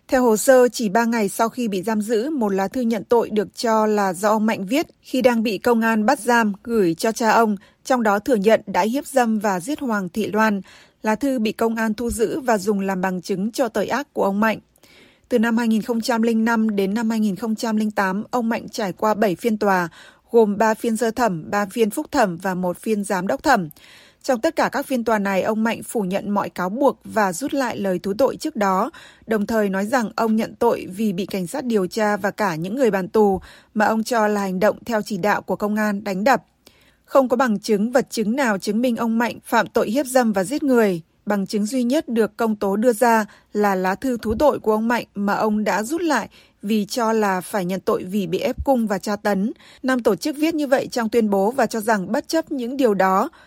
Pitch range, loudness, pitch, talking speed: 205-245 Hz, -20 LUFS, 220 Hz, 245 wpm